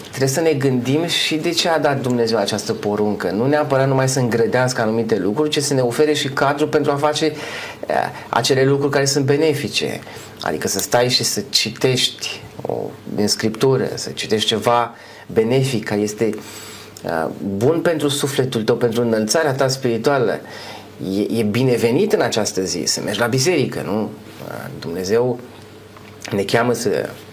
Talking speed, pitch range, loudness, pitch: 160 wpm, 110-145 Hz, -18 LUFS, 125 Hz